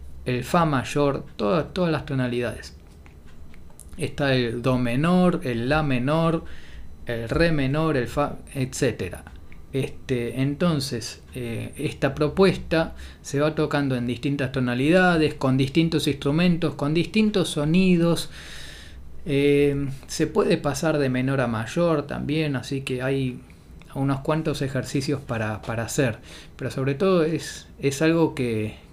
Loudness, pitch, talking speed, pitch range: -24 LUFS, 140 Hz, 130 wpm, 120-155 Hz